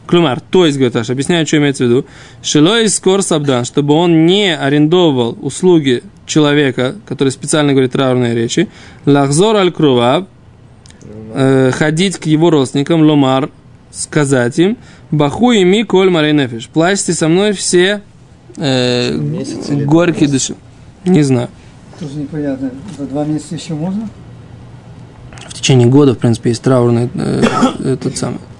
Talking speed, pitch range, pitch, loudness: 125 wpm, 130-170 Hz, 145 Hz, -12 LUFS